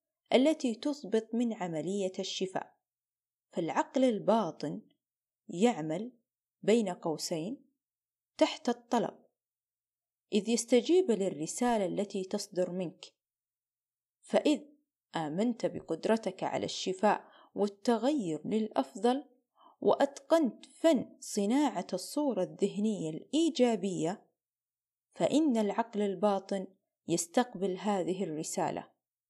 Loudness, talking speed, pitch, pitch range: -32 LUFS, 75 wpm, 215 Hz, 190-255 Hz